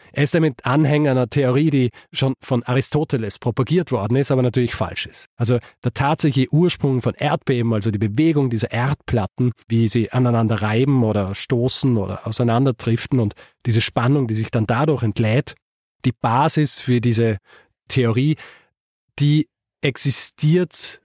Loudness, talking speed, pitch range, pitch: -19 LUFS, 145 wpm, 115-145 Hz, 125 Hz